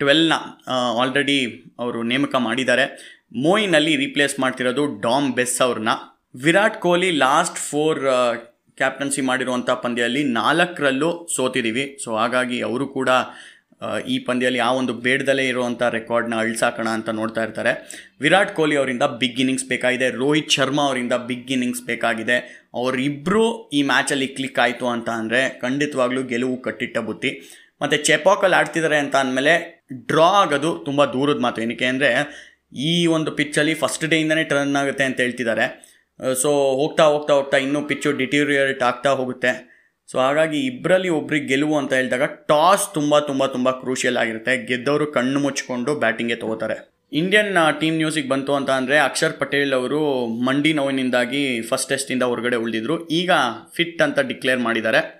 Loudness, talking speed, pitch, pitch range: -20 LUFS, 135 wpm, 135 Hz, 125-150 Hz